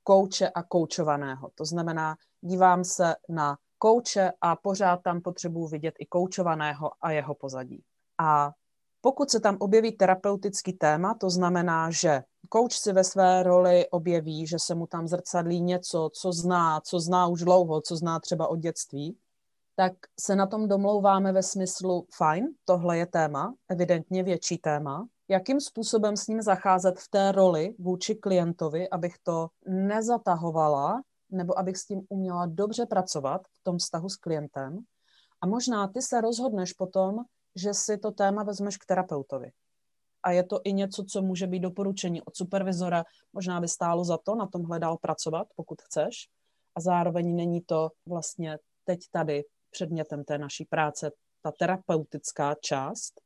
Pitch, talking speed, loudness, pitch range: 180 Hz, 160 wpm, -27 LUFS, 165-195 Hz